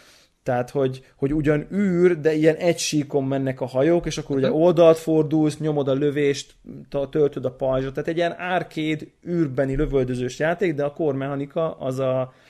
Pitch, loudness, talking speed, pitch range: 150 Hz, -22 LUFS, 165 wpm, 135-160 Hz